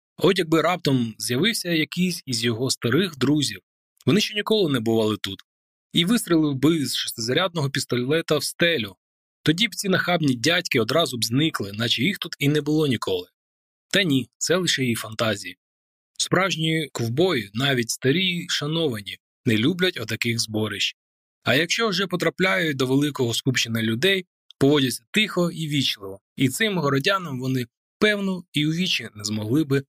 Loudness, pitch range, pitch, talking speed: -22 LUFS, 115-175 Hz, 140 Hz, 155 wpm